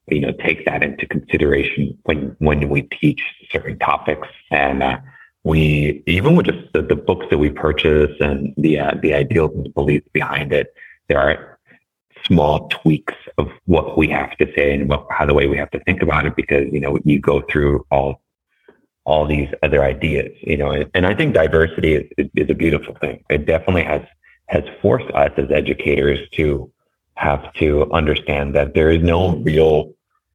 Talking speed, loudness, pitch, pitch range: 185 wpm, -17 LUFS, 75 Hz, 70-80 Hz